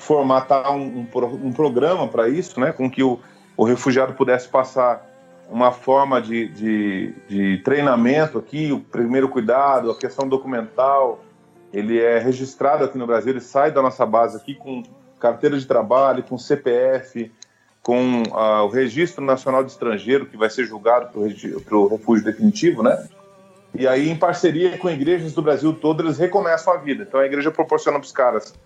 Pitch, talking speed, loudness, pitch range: 130 Hz, 175 wpm, -19 LUFS, 120-145 Hz